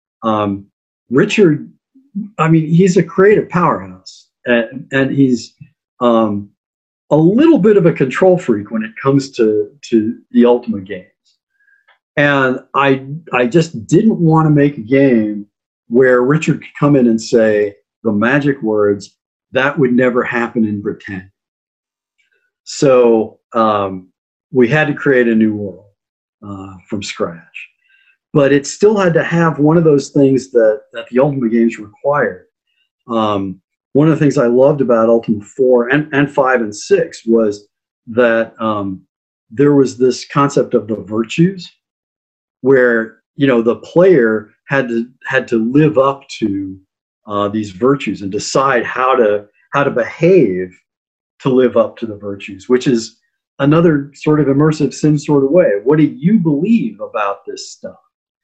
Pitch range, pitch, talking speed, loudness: 110-150 Hz, 130 Hz, 155 wpm, -13 LUFS